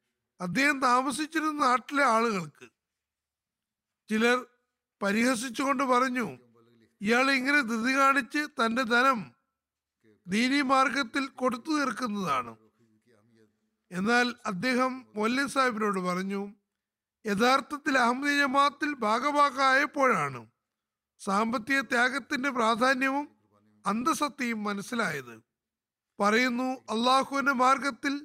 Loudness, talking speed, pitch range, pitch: -27 LUFS, 75 wpm, 200-275 Hz, 245 Hz